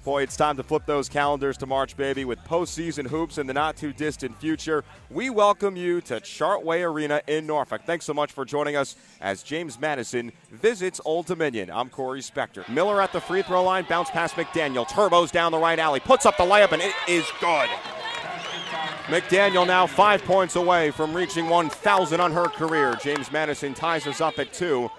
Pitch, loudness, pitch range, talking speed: 160 Hz, -24 LUFS, 145-175 Hz, 195 wpm